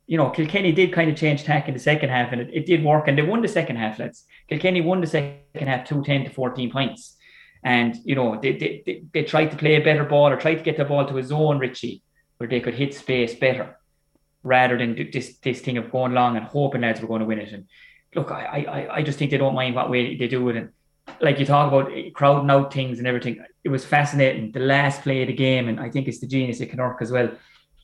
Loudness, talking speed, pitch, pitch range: -22 LUFS, 265 wpm, 135 Hz, 125-150 Hz